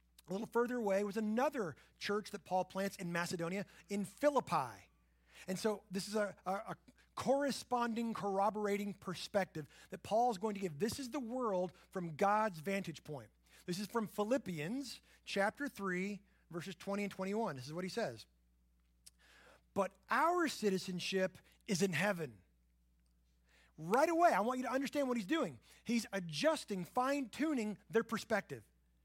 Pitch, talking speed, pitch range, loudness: 200 Hz, 150 wpm, 170-225 Hz, -38 LUFS